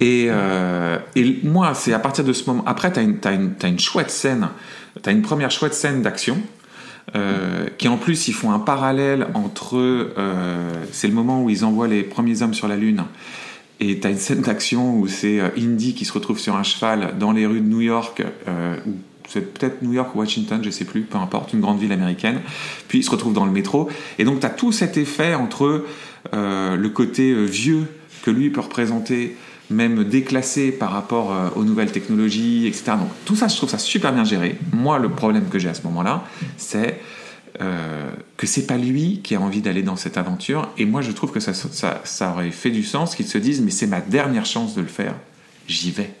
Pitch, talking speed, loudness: 130 Hz, 225 wpm, -20 LUFS